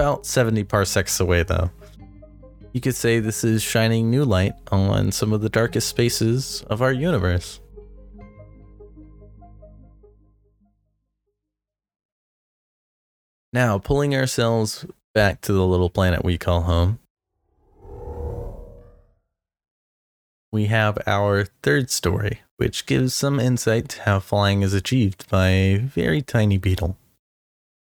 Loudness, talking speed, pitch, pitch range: -21 LUFS, 110 wpm, 105 Hz, 95-115 Hz